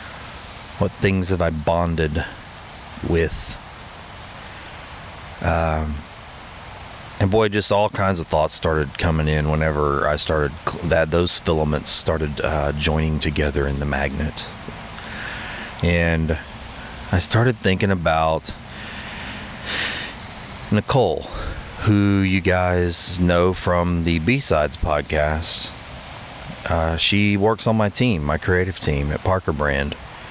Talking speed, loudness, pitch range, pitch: 110 wpm, -21 LUFS, 75-95 Hz, 85 Hz